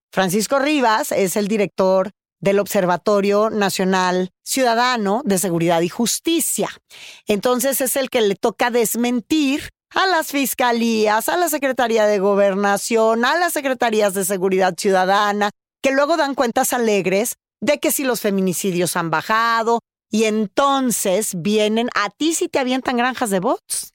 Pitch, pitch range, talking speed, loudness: 220 Hz, 200-265 Hz, 145 wpm, -18 LUFS